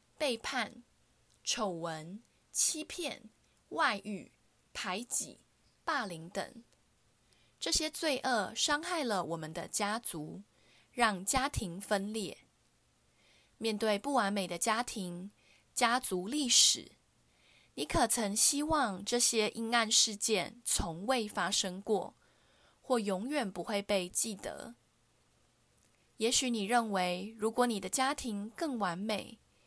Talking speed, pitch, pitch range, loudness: 160 characters per minute, 220 Hz, 195-250 Hz, -32 LUFS